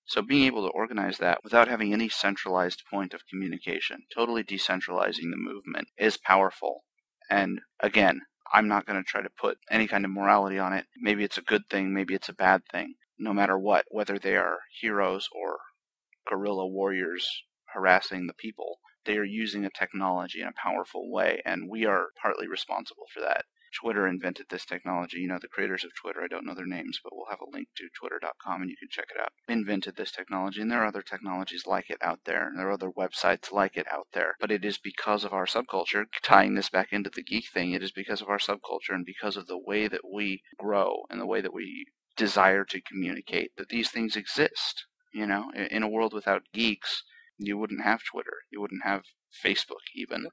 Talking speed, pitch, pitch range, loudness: 210 wpm, 100 Hz, 95-110 Hz, -29 LUFS